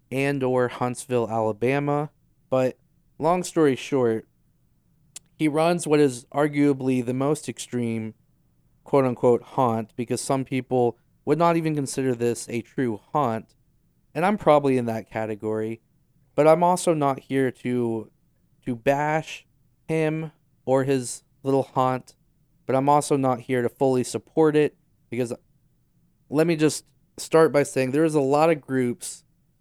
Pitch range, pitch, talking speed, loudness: 125-150 Hz, 135 Hz, 140 wpm, -24 LUFS